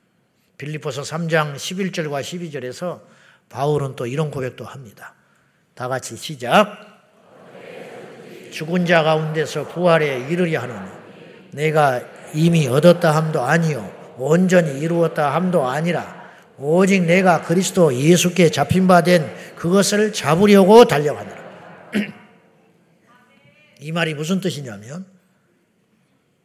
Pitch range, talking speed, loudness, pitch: 150-180 Hz, 235 characters per minute, -18 LUFS, 165 Hz